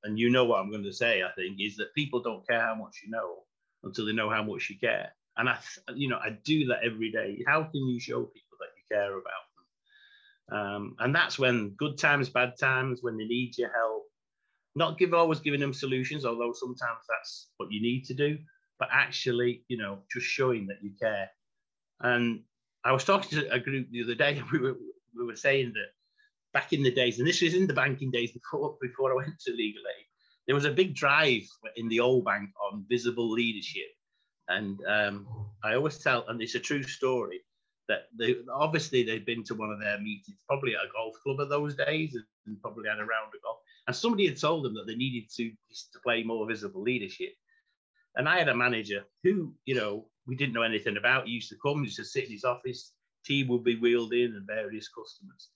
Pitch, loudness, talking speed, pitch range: 125 Hz, -30 LUFS, 225 wpm, 115-155 Hz